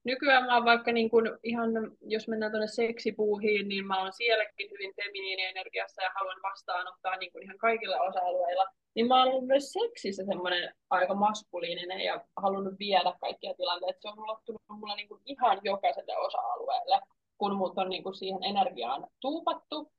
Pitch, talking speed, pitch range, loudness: 210 Hz, 155 wpm, 190-235 Hz, -30 LUFS